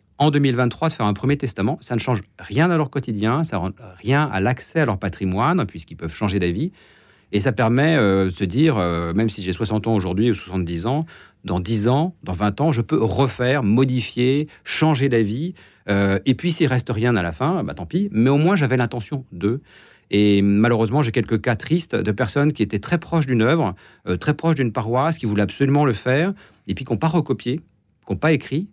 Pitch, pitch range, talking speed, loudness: 120 Hz, 105-145 Hz, 225 wpm, -20 LUFS